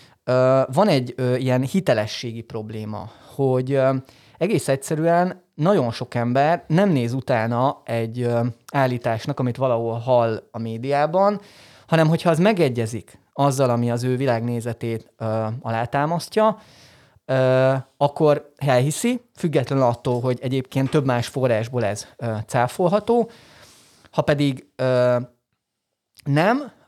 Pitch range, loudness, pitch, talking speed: 120-155 Hz, -21 LUFS, 130 Hz, 120 wpm